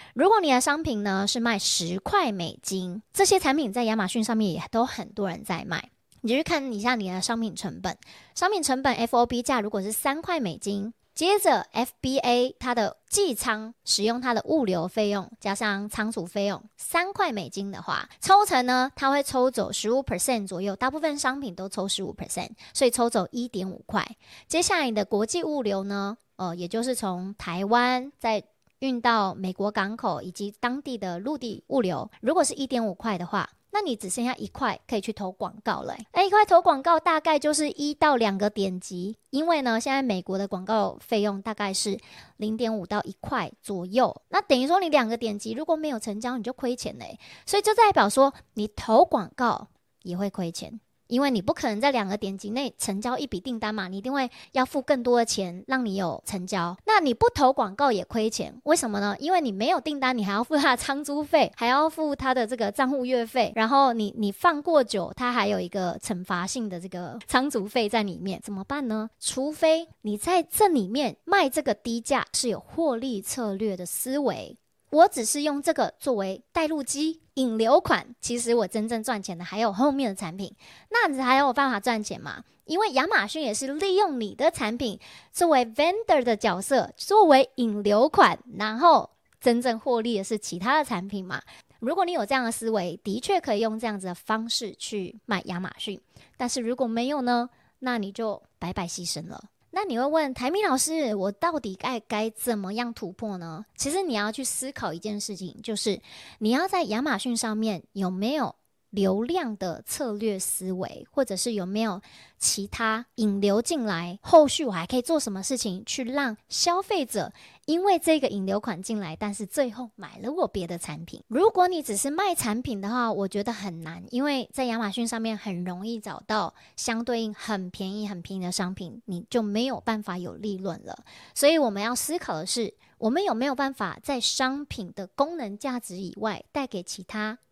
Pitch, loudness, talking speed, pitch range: 230 Hz, -26 LUFS, 295 characters per minute, 205-275 Hz